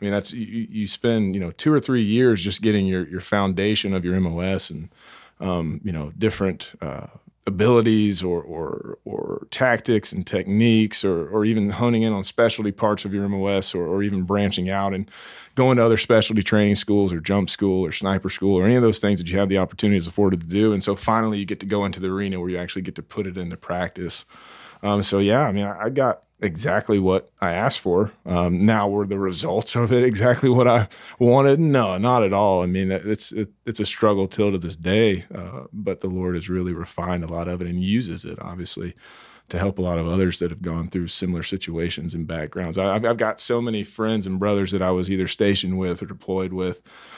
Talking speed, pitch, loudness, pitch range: 230 wpm, 100 Hz, -22 LUFS, 90-110 Hz